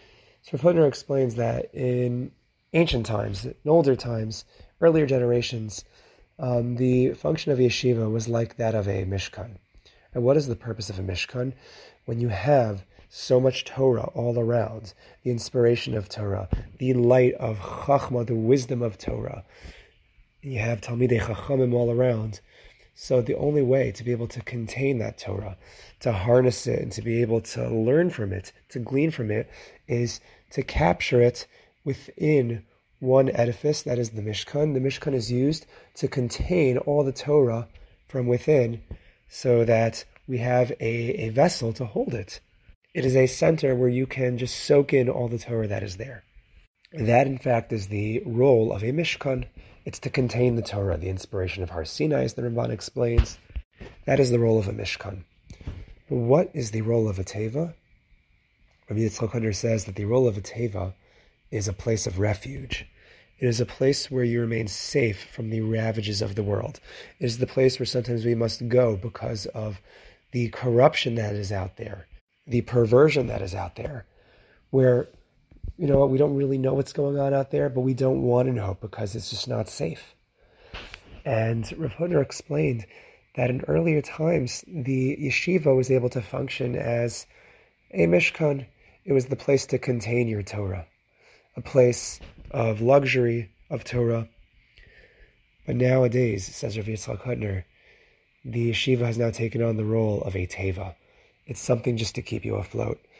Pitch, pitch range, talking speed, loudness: 120 Hz, 110-130 Hz, 170 wpm, -25 LUFS